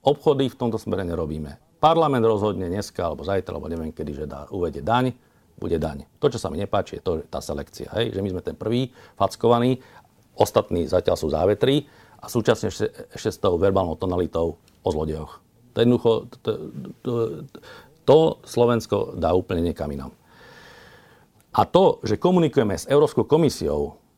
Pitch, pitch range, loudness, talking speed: 105 Hz, 80-120 Hz, -23 LUFS, 160 wpm